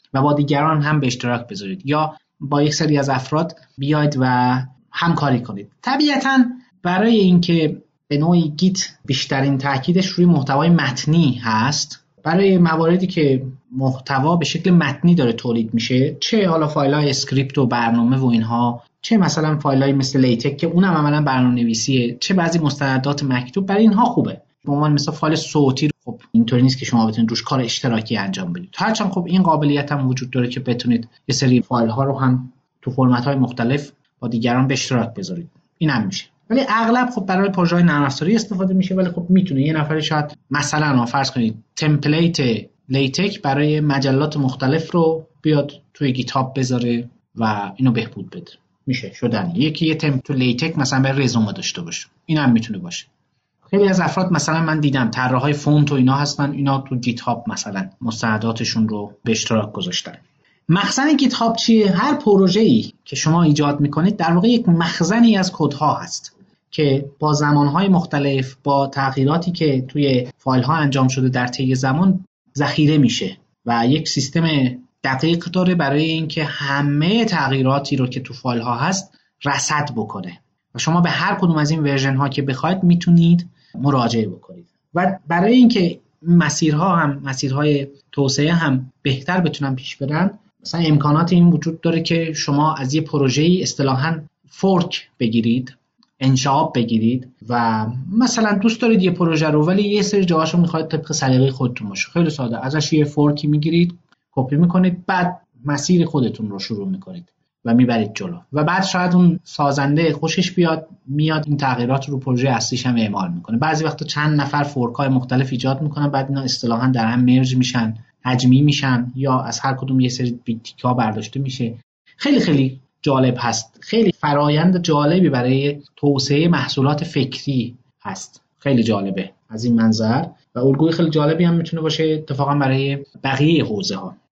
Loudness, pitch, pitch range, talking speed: -18 LUFS, 145 Hz, 130-170 Hz, 165 wpm